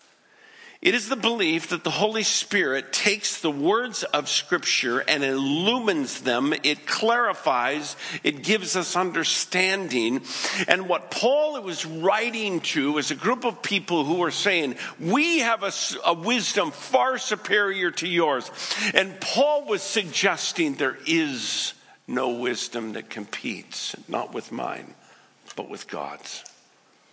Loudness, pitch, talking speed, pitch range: -24 LUFS, 200 Hz, 135 wpm, 170-245 Hz